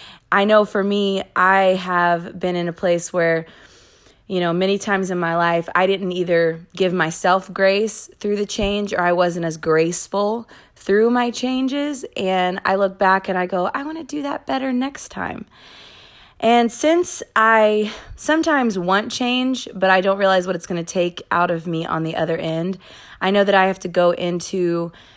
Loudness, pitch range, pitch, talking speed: -19 LUFS, 175-215 Hz, 190 Hz, 190 wpm